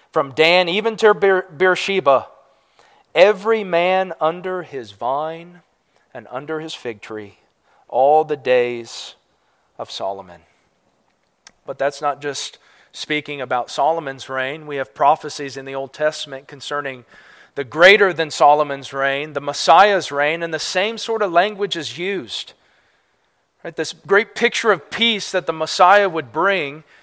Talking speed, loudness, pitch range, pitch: 140 wpm, -18 LUFS, 135-185 Hz, 155 Hz